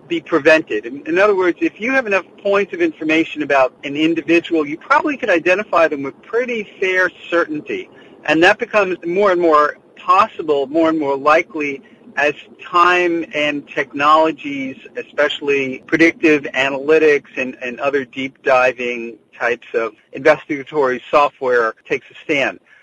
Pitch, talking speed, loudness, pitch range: 165 Hz, 140 wpm, -16 LUFS, 145-205 Hz